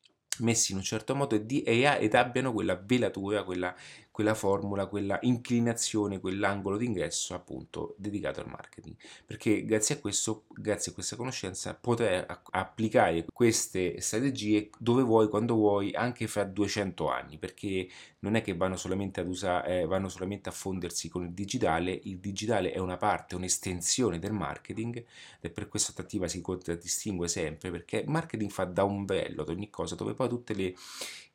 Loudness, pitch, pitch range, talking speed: -31 LUFS, 100 Hz, 95-110 Hz, 165 wpm